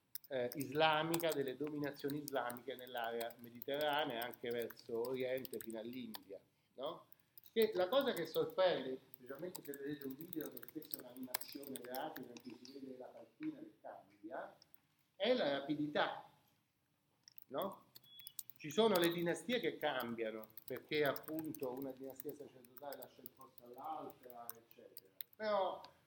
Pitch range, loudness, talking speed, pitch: 125-160 Hz, -41 LUFS, 125 wpm, 140 Hz